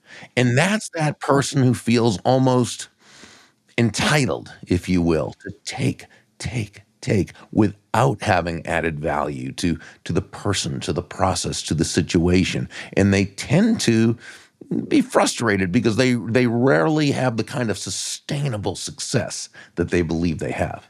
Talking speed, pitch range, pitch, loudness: 145 wpm, 90-125 Hz, 110 Hz, -21 LUFS